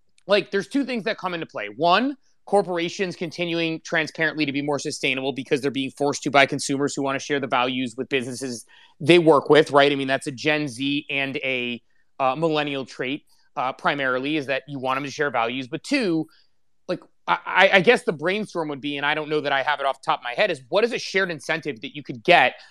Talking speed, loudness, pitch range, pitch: 240 wpm, -22 LUFS, 135-170 Hz, 145 Hz